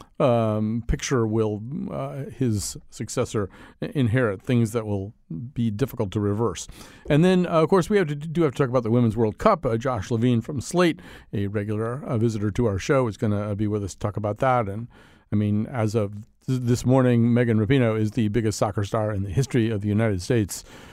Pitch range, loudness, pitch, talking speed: 105-130 Hz, -24 LUFS, 115 Hz, 215 wpm